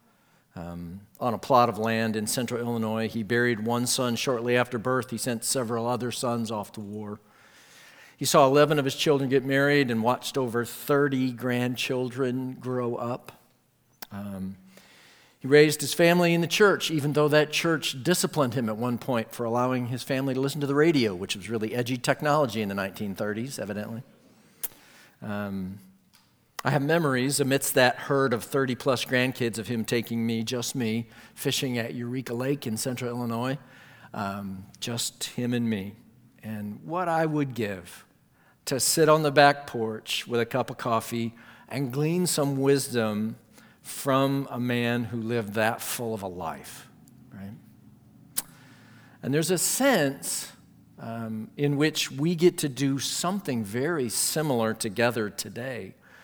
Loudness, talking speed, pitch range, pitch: -26 LUFS, 160 wpm, 115-140 Hz, 125 Hz